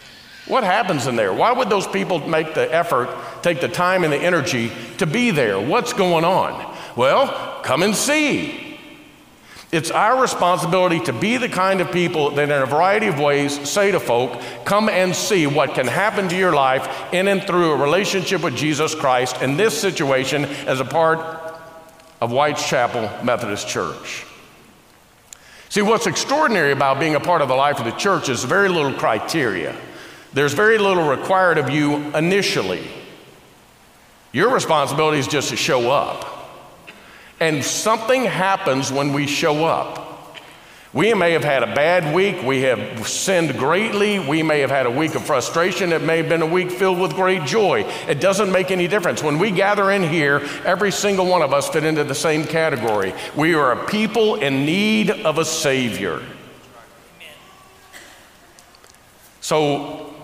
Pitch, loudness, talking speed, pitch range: 160 Hz, -18 LUFS, 170 wpm, 145-190 Hz